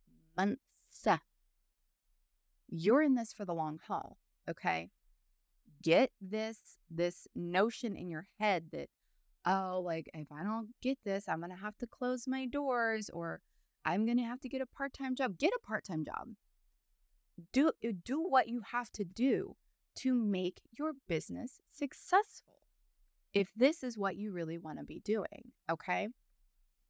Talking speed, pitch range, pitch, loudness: 150 wpm, 160-250 Hz, 200 Hz, -36 LUFS